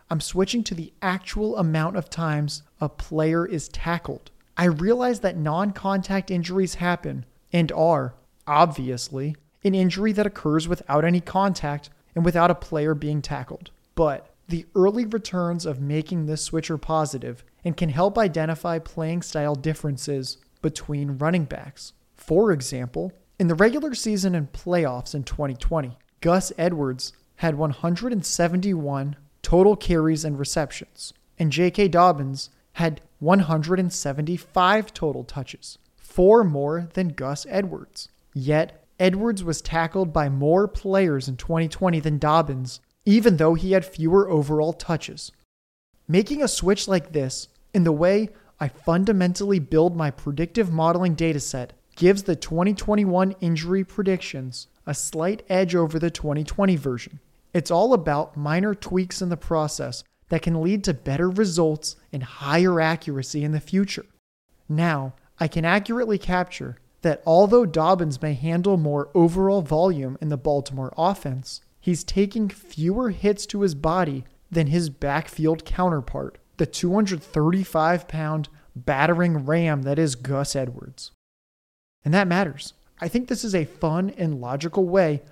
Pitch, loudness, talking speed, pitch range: 165 Hz, -23 LUFS, 140 wpm, 150-185 Hz